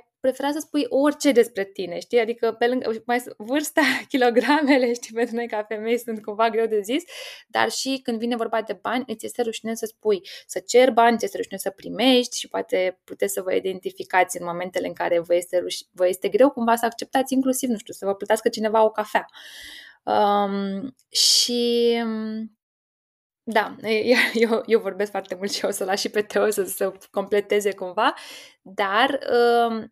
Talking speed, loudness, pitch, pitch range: 175 wpm, -22 LUFS, 230 Hz, 205-250 Hz